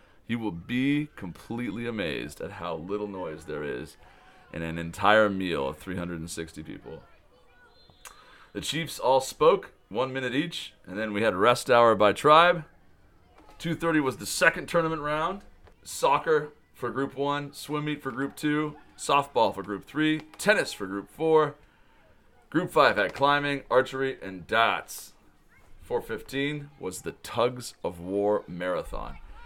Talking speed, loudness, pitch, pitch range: 145 wpm, -27 LUFS, 130 Hz, 100-150 Hz